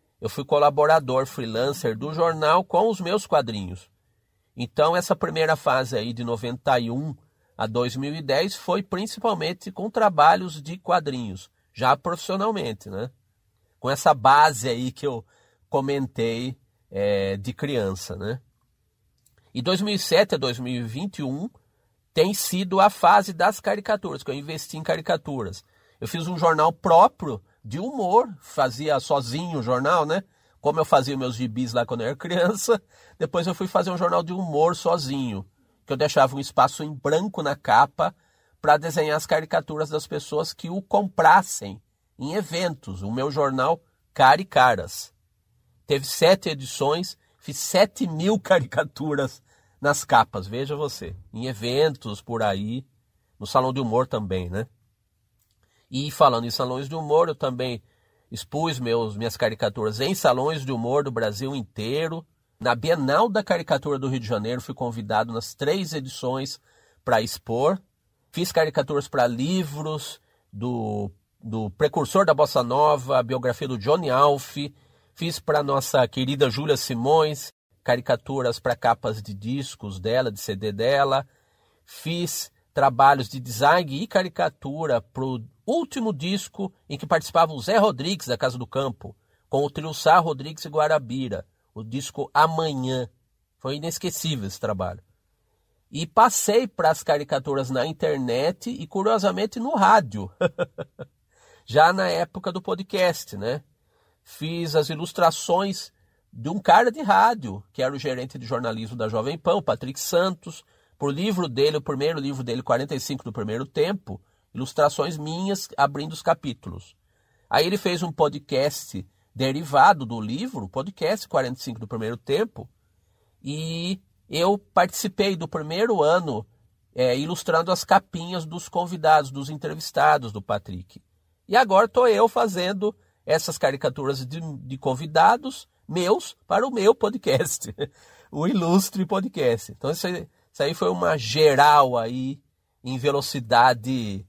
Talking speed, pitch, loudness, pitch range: 140 wpm, 140 Hz, -23 LUFS, 120-165 Hz